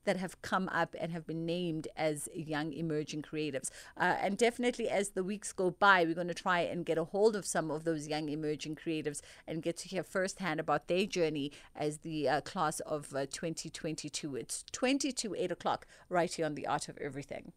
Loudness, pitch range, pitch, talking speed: -35 LUFS, 150-185 Hz, 165 Hz, 205 wpm